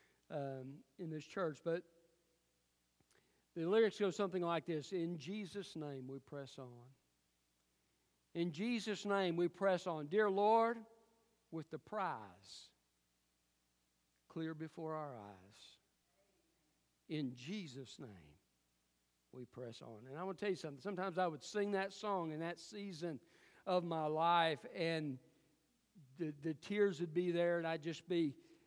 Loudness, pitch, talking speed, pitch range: -41 LUFS, 160 Hz, 140 wpm, 125-185 Hz